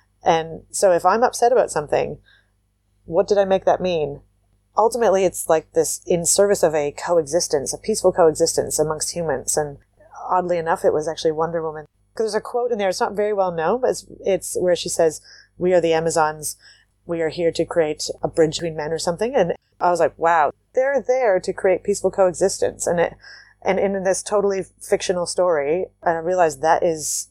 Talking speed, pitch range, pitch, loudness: 200 wpm, 160-190 Hz, 170 Hz, -20 LUFS